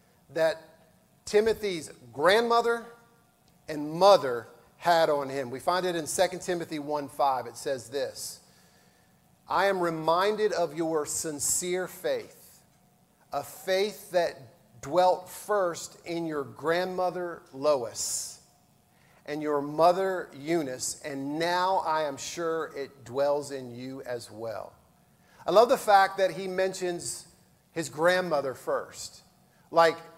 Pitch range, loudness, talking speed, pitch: 150-185 Hz, -28 LUFS, 120 wpm, 170 Hz